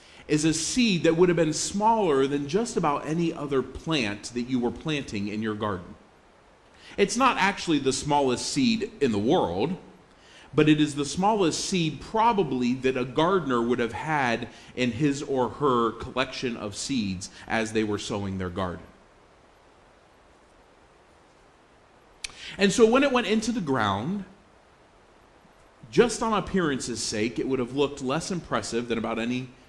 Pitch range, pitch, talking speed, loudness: 115-180 Hz, 135 Hz, 155 wpm, -26 LUFS